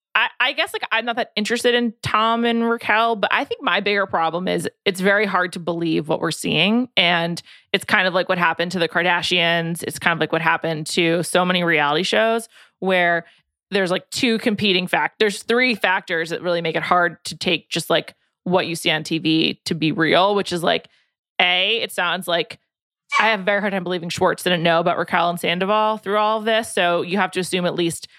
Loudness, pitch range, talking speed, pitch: -19 LUFS, 170-215 Hz, 225 wpm, 185 Hz